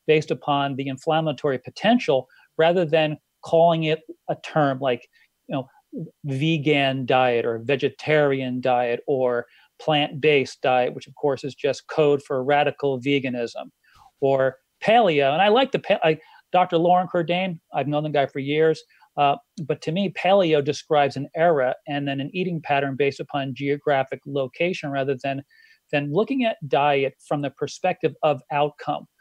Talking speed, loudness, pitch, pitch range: 155 wpm, -22 LUFS, 145 Hz, 135-165 Hz